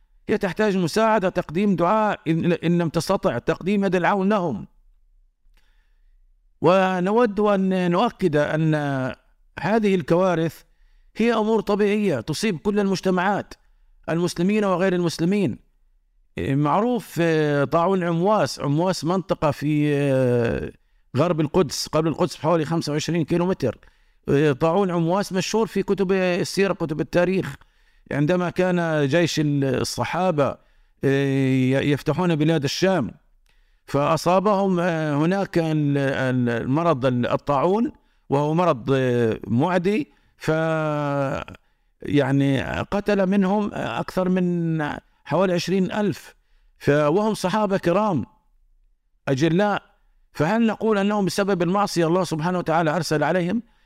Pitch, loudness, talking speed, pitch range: 175 Hz, -22 LUFS, 95 wpm, 150-195 Hz